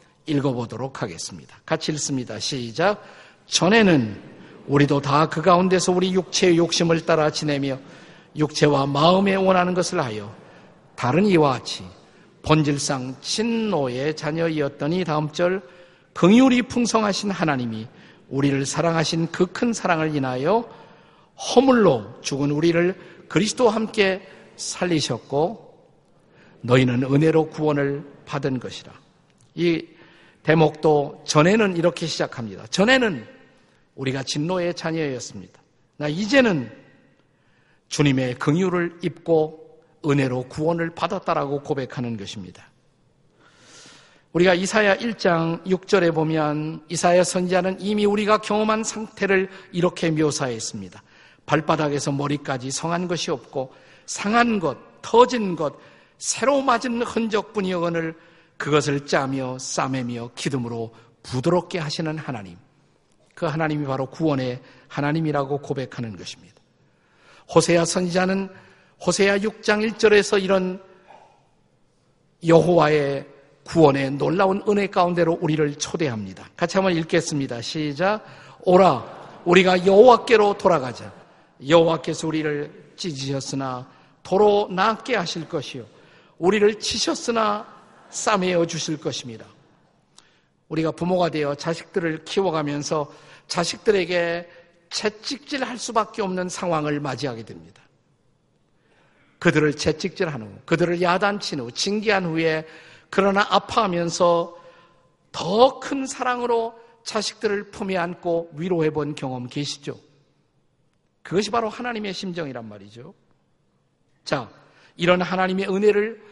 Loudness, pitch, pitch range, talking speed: -22 LUFS, 165 Hz, 145-190 Hz, 275 characters per minute